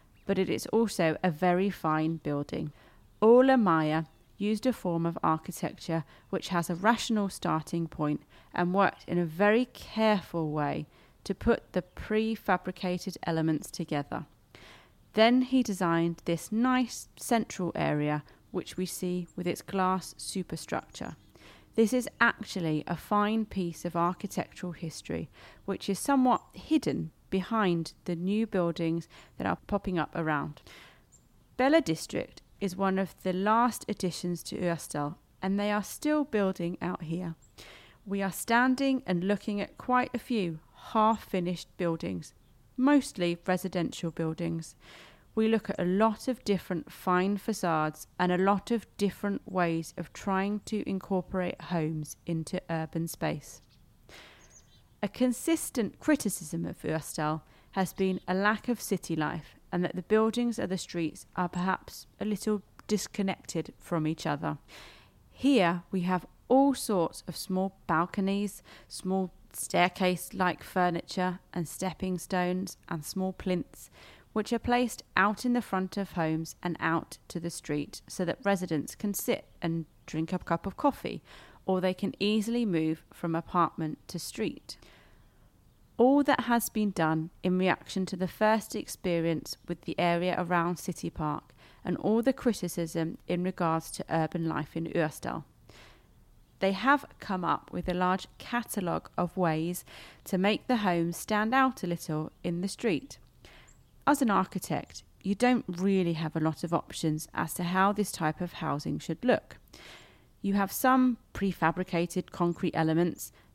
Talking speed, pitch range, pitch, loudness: 145 wpm, 165-205 Hz, 180 Hz, -30 LUFS